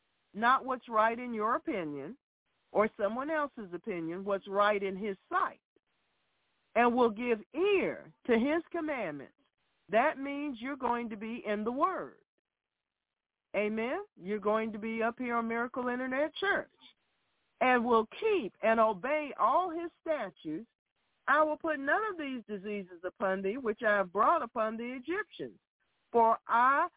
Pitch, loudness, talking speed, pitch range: 235 Hz, -32 LUFS, 150 wpm, 215-300 Hz